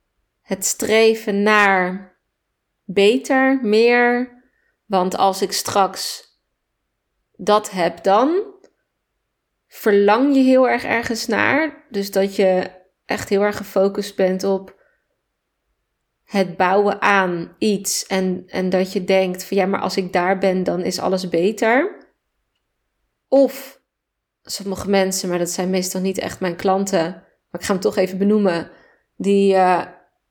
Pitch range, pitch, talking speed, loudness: 185-220 Hz, 195 Hz, 135 wpm, -18 LUFS